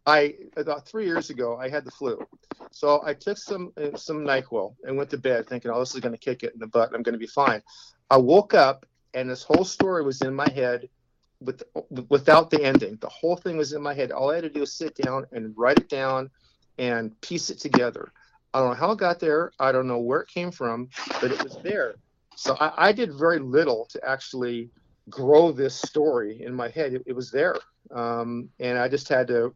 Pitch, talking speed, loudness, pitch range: 135 Hz, 235 wpm, -24 LUFS, 125-150 Hz